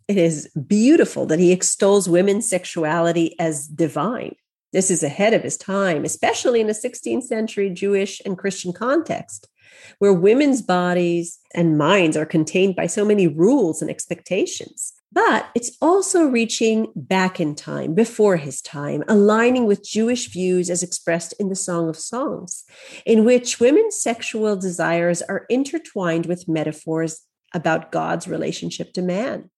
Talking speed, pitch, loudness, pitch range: 150 wpm, 190 Hz, -20 LUFS, 170-225 Hz